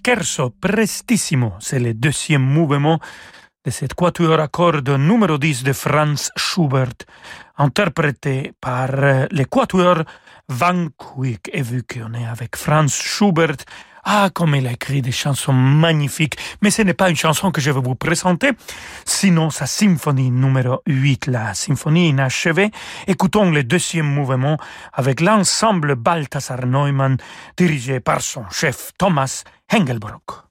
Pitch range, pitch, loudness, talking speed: 135-175 Hz, 150 Hz, -17 LUFS, 135 wpm